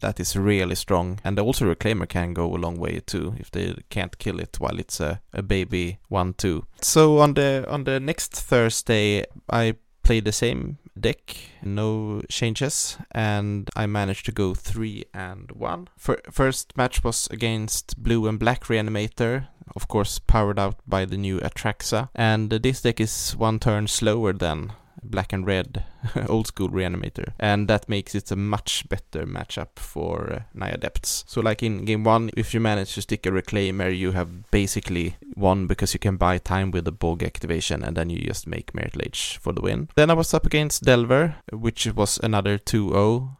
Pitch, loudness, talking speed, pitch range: 105 Hz, -24 LUFS, 185 wpm, 95-115 Hz